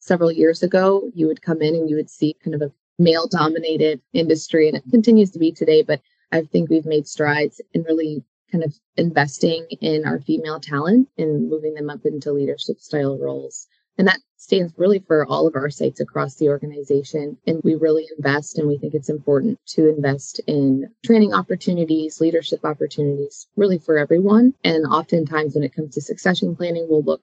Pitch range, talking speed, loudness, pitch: 150-170 Hz, 190 wpm, -19 LUFS, 155 Hz